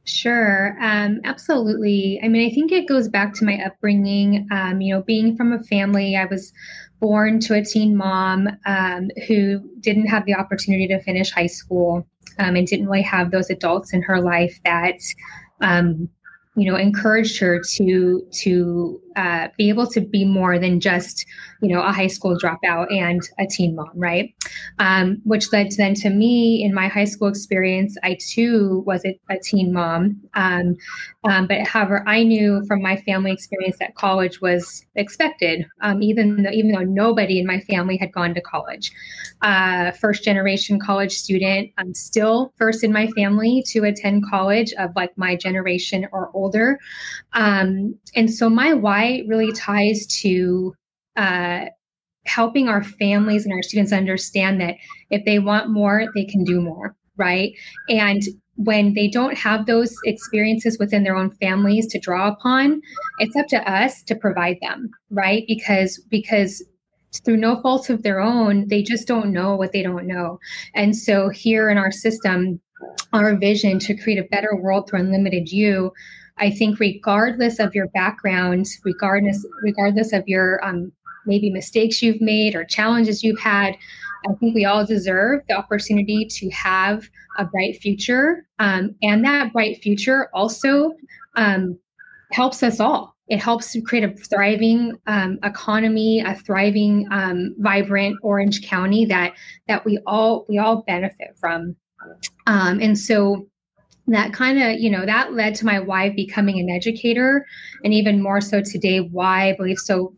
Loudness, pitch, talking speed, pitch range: -19 LUFS, 200 Hz, 165 wpm, 190-220 Hz